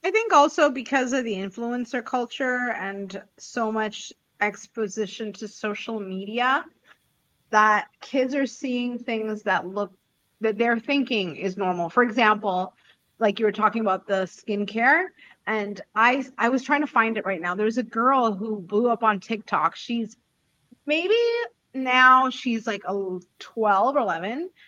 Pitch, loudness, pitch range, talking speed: 225 Hz, -24 LUFS, 205-255 Hz, 155 wpm